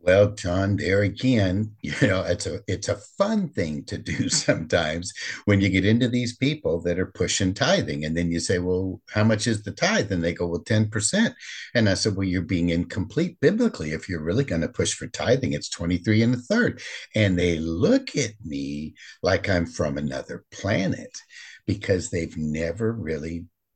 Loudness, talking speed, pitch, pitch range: -24 LUFS, 190 wpm, 95 Hz, 85-110 Hz